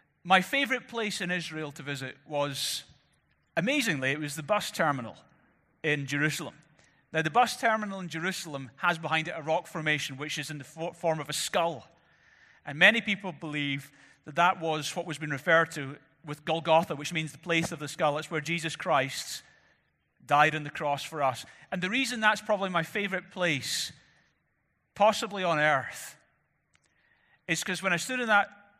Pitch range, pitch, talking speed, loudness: 150-190 Hz, 160 Hz, 175 wpm, -29 LUFS